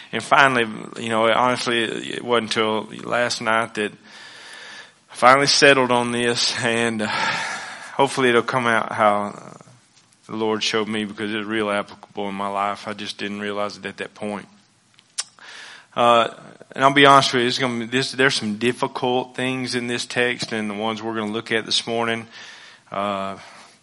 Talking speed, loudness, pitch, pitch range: 180 wpm, -20 LUFS, 115 Hz, 105-125 Hz